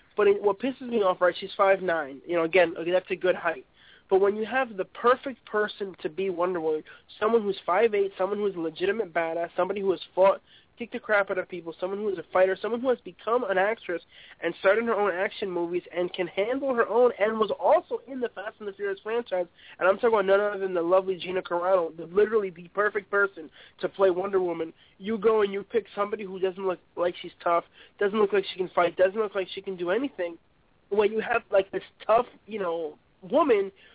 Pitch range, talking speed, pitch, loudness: 180-215 Hz, 235 wpm, 195 Hz, -27 LUFS